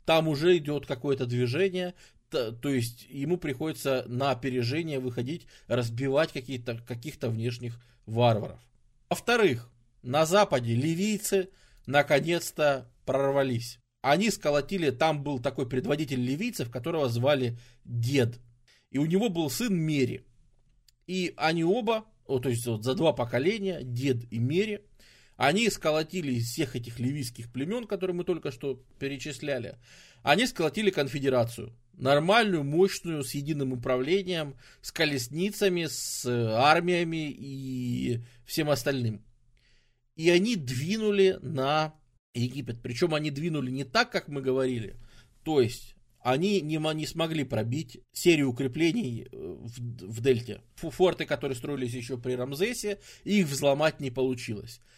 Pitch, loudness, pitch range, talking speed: 140 Hz, -28 LUFS, 125-160 Hz, 120 wpm